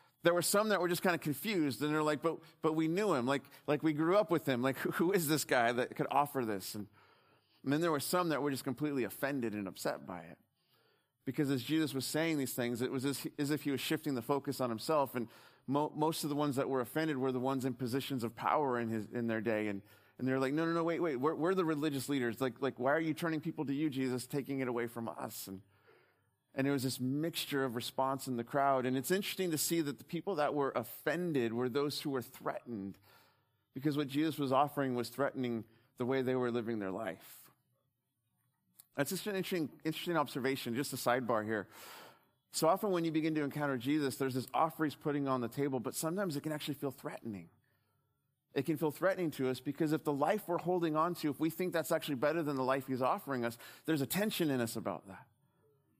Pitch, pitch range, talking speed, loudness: 140 Hz, 125-155 Hz, 240 wpm, -35 LUFS